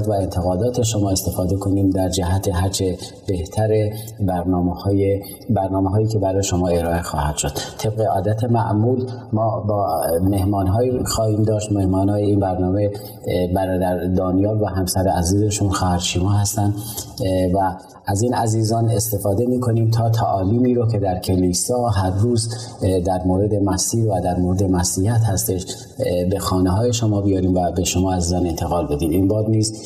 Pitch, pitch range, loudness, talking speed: 100 Hz, 95-110 Hz, -19 LUFS, 150 wpm